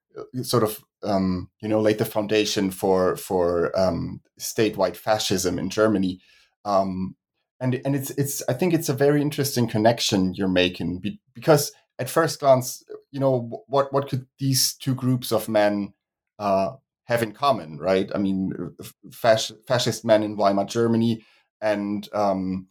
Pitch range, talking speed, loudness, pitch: 100-130 Hz, 155 wpm, -23 LUFS, 110 Hz